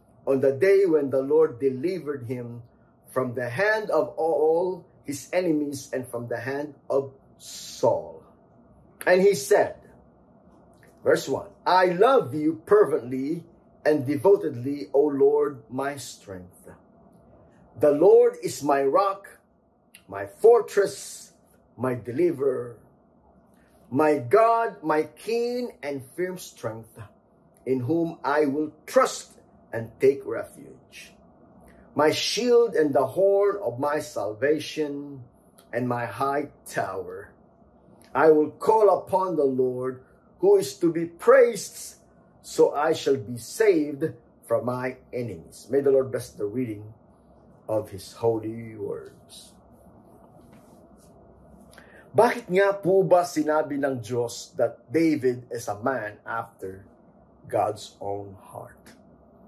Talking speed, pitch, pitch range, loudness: 115 wpm, 150 Hz, 130-195 Hz, -24 LUFS